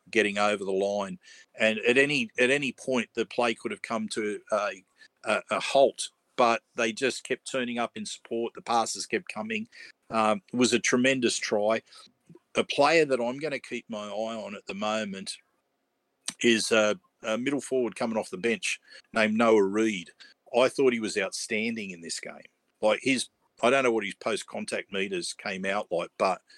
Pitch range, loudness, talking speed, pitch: 105-125 Hz, -27 LUFS, 190 wpm, 115 Hz